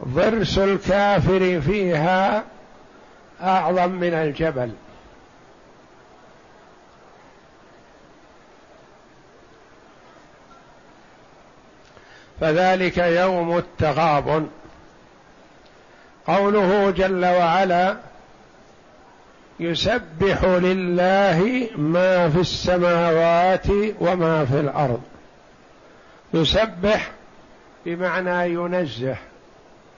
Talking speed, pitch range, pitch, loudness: 45 wpm, 165-190 Hz, 180 Hz, -20 LUFS